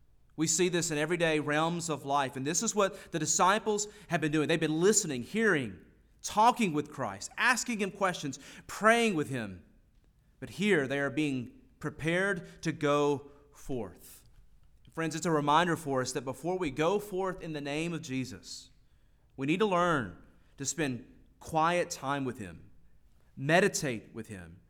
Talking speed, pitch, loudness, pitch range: 165 wpm, 155 Hz, -30 LUFS, 135-180 Hz